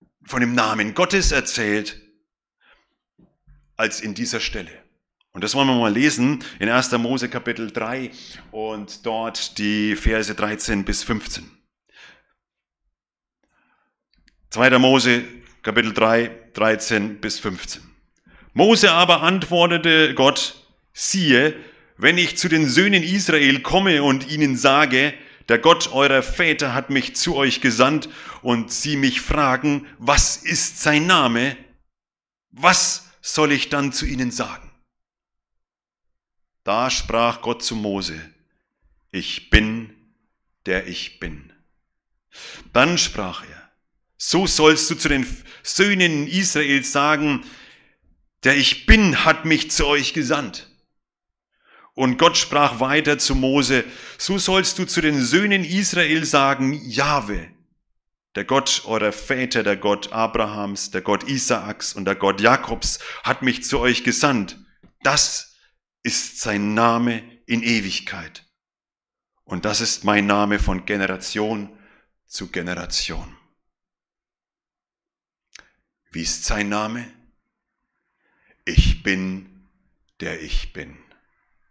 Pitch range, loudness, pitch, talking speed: 105-150 Hz, -19 LUFS, 125 Hz, 115 wpm